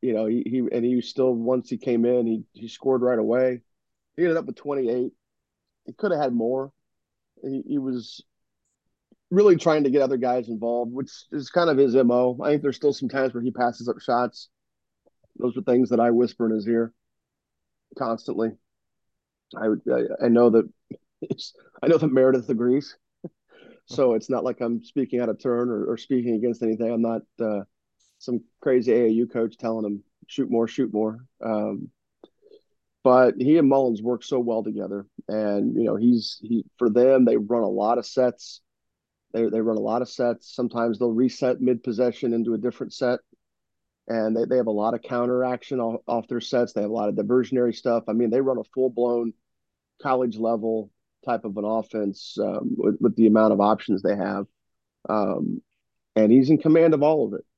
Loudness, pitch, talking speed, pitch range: -23 LUFS, 120 Hz, 195 wpm, 115-130 Hz